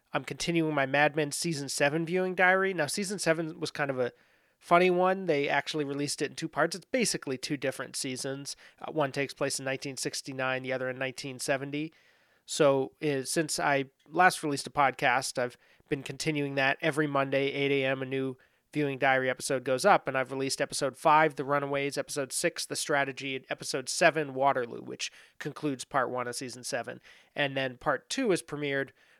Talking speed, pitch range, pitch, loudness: 185 wpm, 135-155 Hz, 140 Hz, -29 LUFS